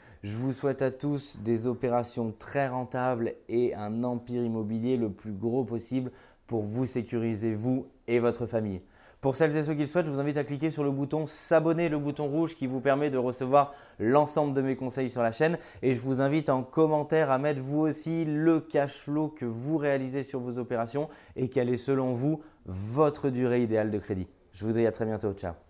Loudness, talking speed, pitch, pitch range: -29 LUFS, 215 wpm, 130 Hz, 115-145 Hz